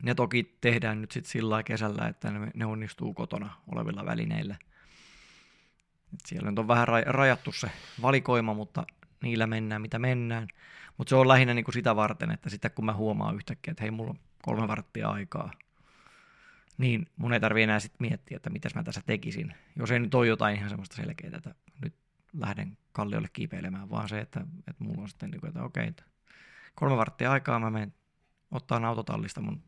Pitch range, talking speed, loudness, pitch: 110-135 Hz, 180 wpm, -30 LUFS, 120 Hz